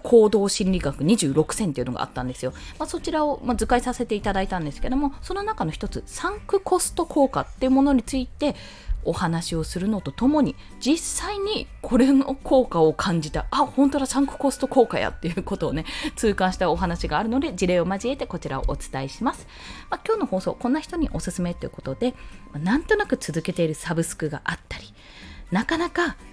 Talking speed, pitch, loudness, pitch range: 410 characters per minute, 225 Hz, -24 LUFS, 165-280 Hz